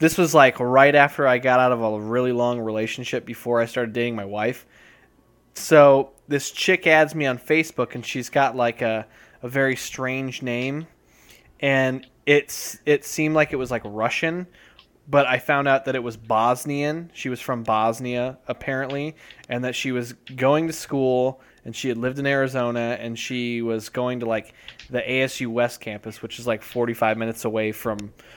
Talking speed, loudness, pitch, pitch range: 185 wpm, -22 LUFS, 125 Hz, 115-140 Hz